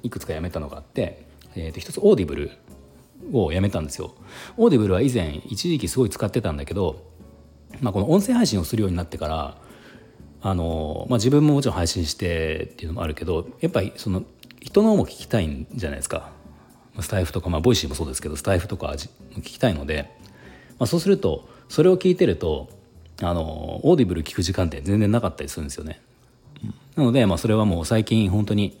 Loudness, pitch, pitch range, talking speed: -23 LUFS, 95 Hz, 80-120 Hz, 440 characters per minute